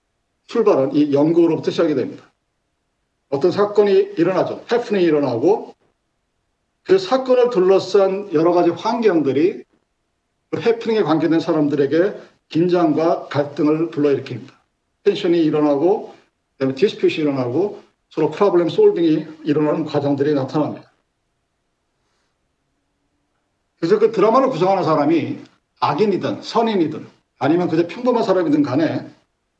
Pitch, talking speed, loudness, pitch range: 175 Hz, 300 characters per minute, -18 LUFS, 150-220 Hz